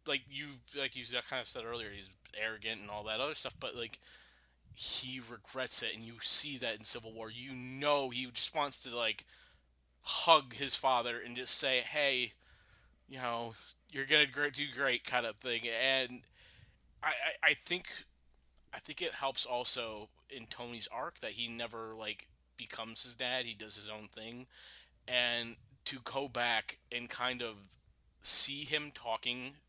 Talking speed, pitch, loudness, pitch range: 170 wpm, 120 Hz, -34 LUFS, 110-130 Hz